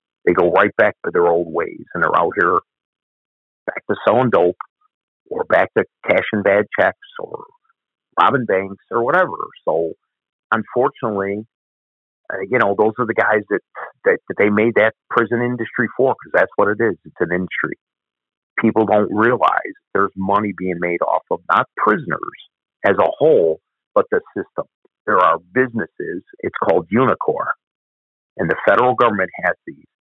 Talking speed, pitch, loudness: 165 wpm, 110 Hz, -18 LUFS